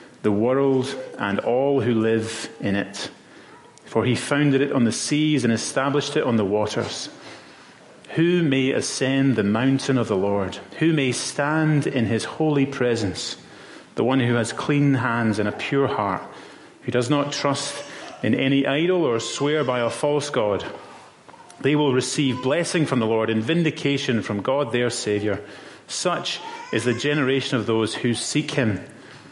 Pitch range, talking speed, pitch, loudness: 115-145 Hz, 165 wpm, 130 Hz, -22 LUFS